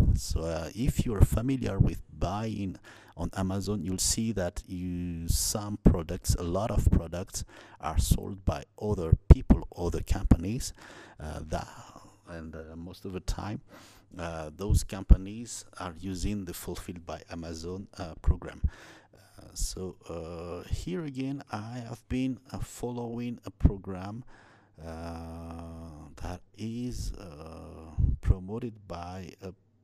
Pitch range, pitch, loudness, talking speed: 85-105 Hz, 95 Hz, -32 LUFS, 130 wpm